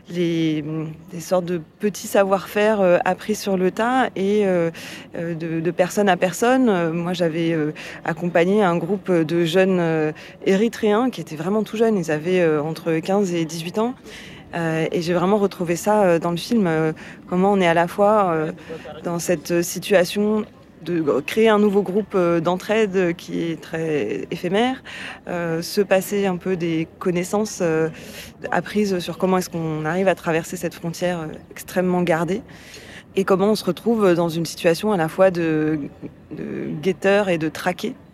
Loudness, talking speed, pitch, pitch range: -21 LUFS, 170 wpm, 180 Hz, 165-200 Hz